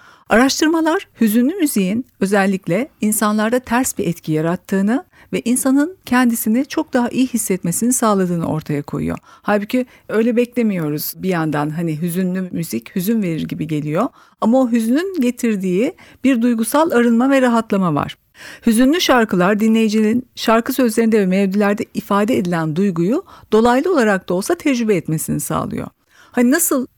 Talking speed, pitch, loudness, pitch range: 135 wpm, 225 Hz, -17 LUFS, 185-255 Hz